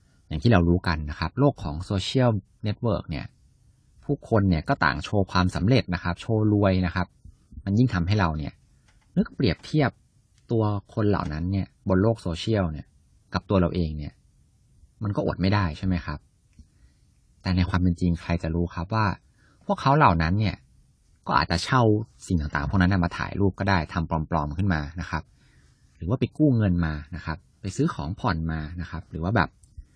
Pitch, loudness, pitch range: 90 Hz, -25 LUFS, 85-105 Hz